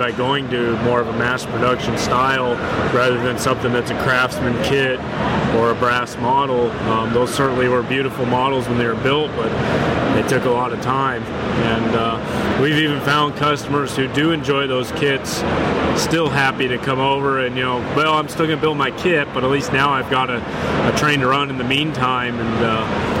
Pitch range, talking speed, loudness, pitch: 120-140 Hz, 205 wpm, -18 LUFS, 130 Hz